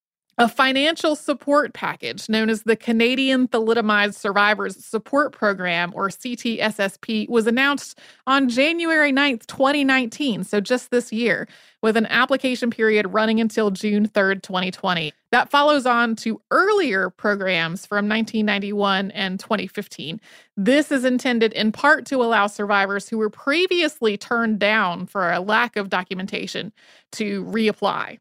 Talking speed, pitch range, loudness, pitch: 135 wpm, 205-260 Hz, -20 LUFS, 225 Hz